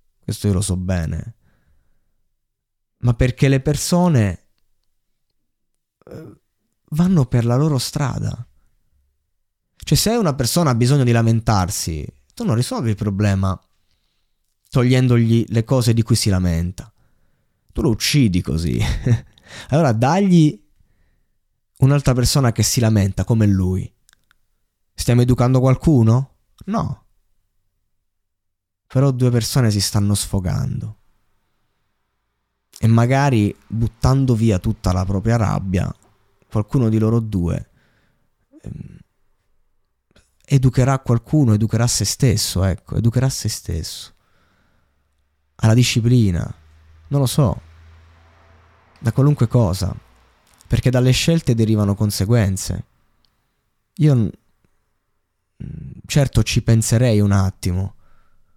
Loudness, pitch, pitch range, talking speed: -18 LUFS, 110 Hz, 95-125 Hz, 100 wpm